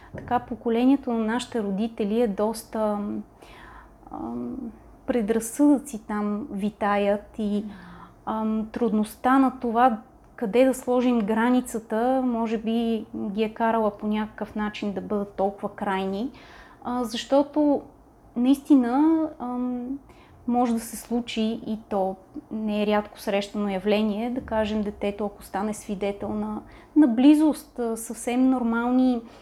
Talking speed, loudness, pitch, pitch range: 120 wpm, -25 LUFS, 225 Hz, 210-245 Hz